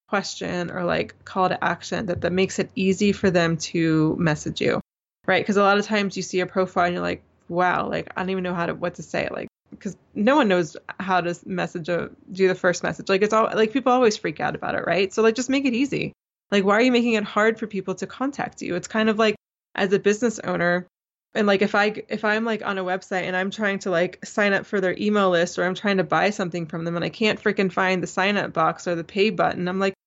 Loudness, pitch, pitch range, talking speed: -23 LUFS, 190 Hz, 180-210 Hz, 265 wpm